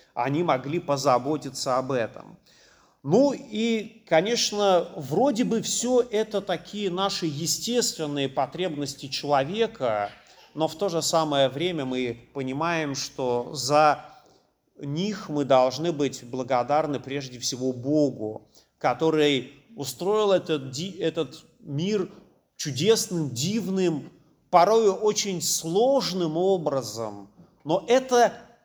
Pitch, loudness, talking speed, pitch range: 160 Hz, -25 LUFS, 100 wpm, 140-195 Hz